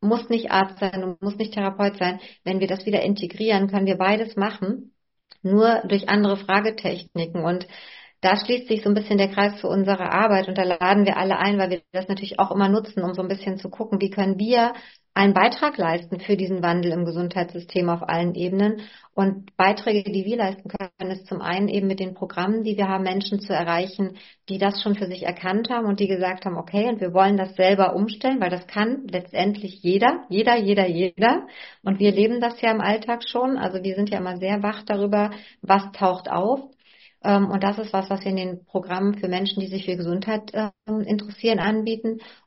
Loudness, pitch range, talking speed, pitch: -23 LUFS, 185-210 Hz, 210 wpm, 195 Hz